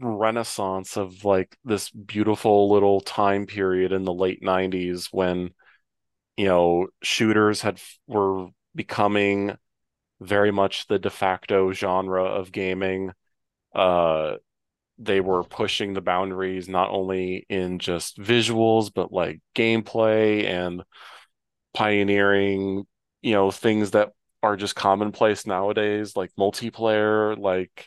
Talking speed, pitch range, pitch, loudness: 115 wpm, 95-105 Hz, 100 Hz, -23 LUFS